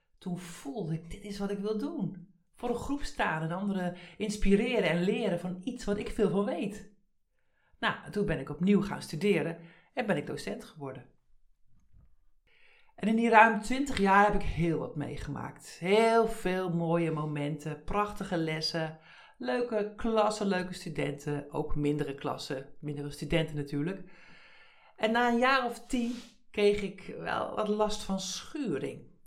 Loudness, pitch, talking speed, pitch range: -31 LUFS, 195 Hz, 160 wpm, 165-220 Hz